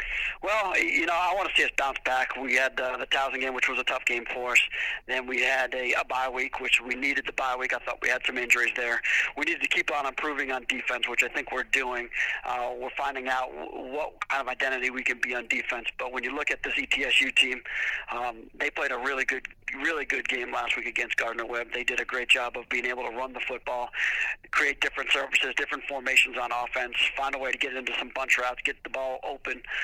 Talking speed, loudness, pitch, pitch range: 245 wpm, -26 LUFS, 130 Hz, 125-130 Hz